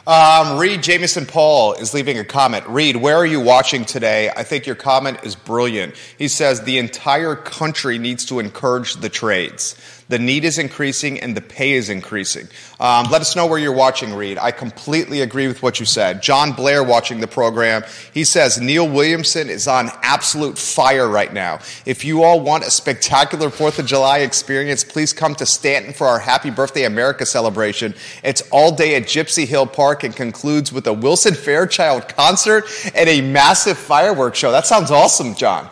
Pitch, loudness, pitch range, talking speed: 135 Hz, -15 LUFS, 120-155 Hz, 190 wpm